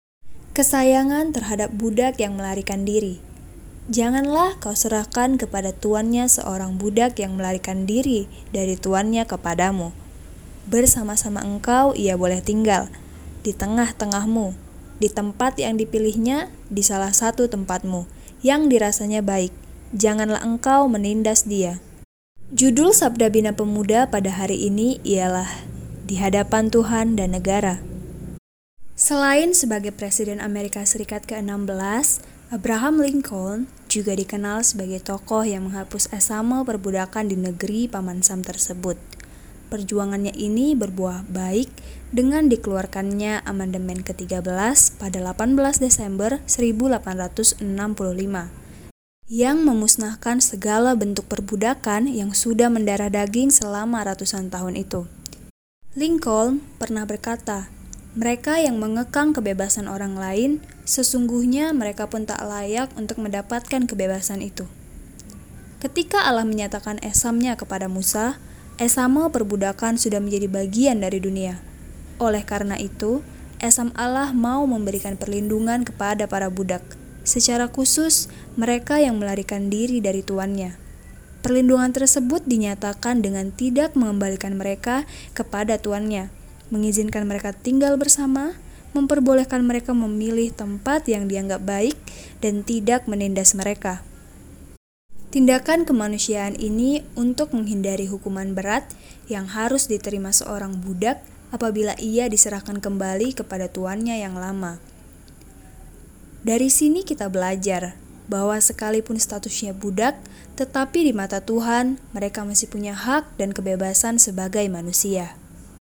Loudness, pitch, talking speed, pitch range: -21 LUFS, 210 Hz, 110 wpm, 195-240 Hz